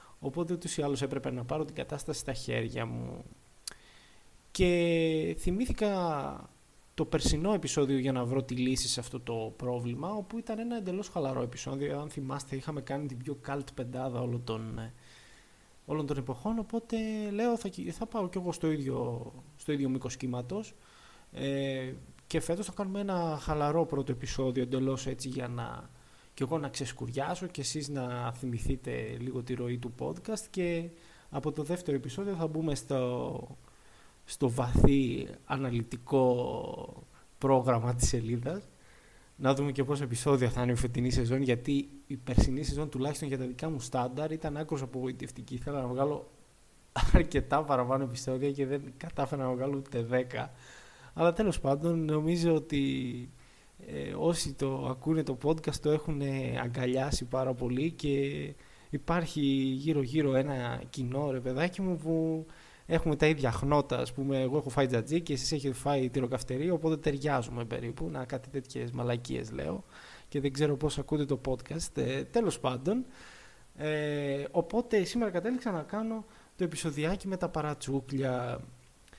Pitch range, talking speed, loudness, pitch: 130-160 Hz, 150 wpm, -33 LUFS, 140 Hz